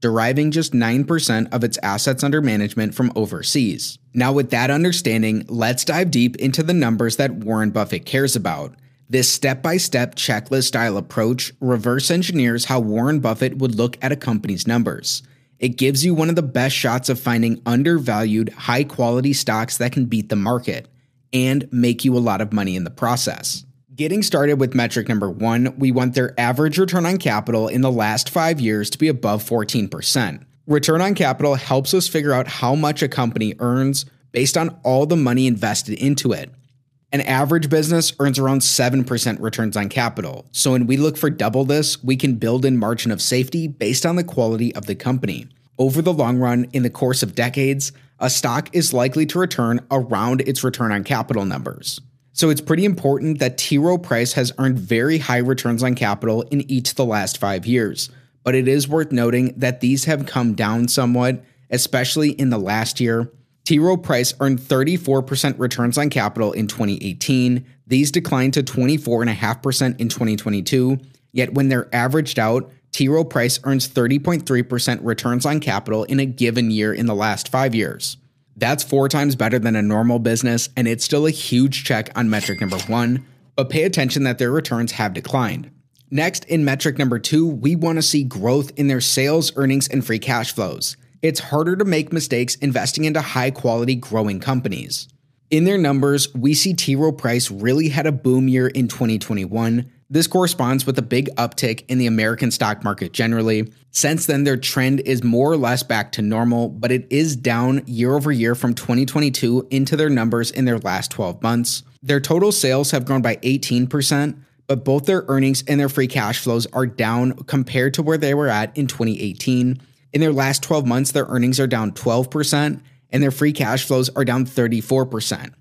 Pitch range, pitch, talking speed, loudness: 120-140 Hz, 130 Hz, 185 wpm, -19 LUFS